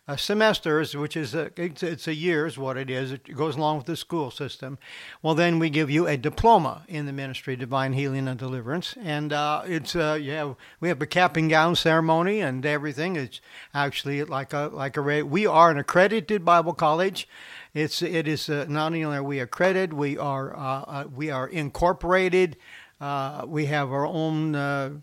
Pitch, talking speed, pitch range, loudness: 150 Hz, 195 wpm, 140-165 Hz, -25 LUFS